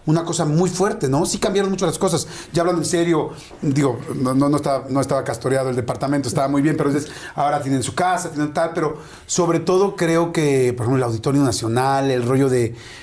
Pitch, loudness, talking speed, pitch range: 145 Hz, -20 LUFS, 215 wpm, 135-170 Hz